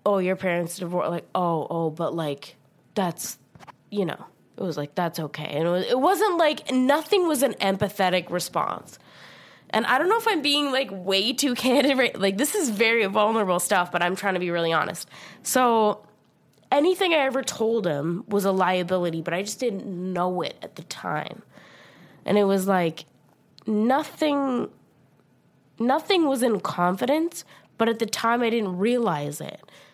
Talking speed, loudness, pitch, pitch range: 175 wpm, -24 LUFS, 200 Hz, 175-260 Hz